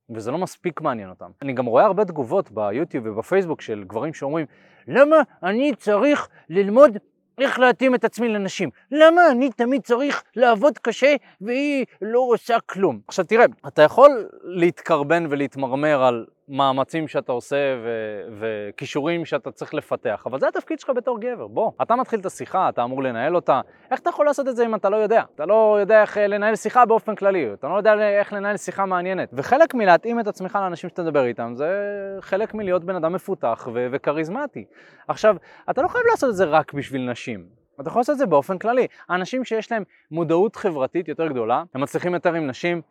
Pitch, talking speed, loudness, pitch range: 195 Hz, 185 wpm, -21 LUFS, 155-235 Hz